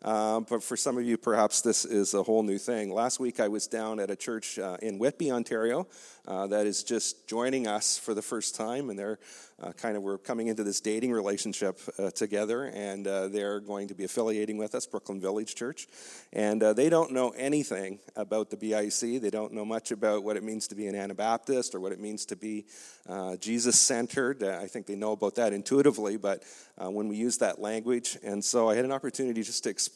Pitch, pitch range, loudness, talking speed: 110 Hz, 105-115 Hz, -30 LUFS, 225 wpm